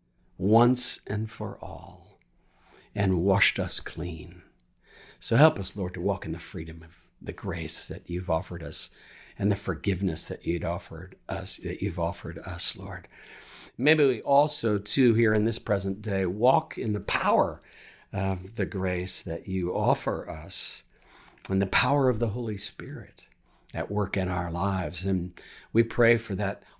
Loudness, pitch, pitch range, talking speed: -26 LUFS, 95 Hz, 90-110 Hz, 165 wpm